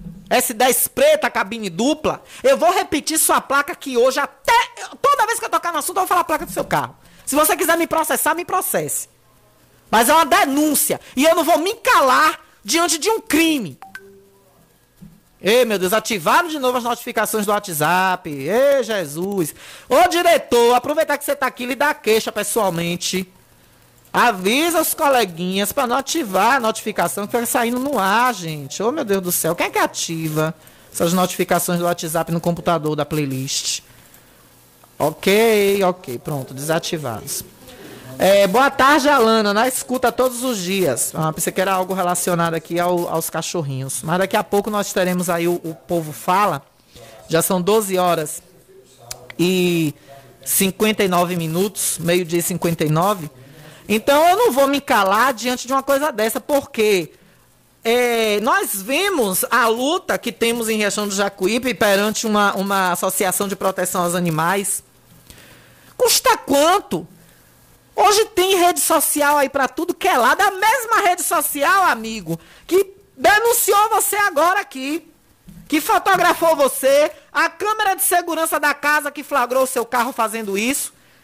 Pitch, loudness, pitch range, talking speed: 225 Hz, -18 LUFS, 180-300 Hz, 160 wpm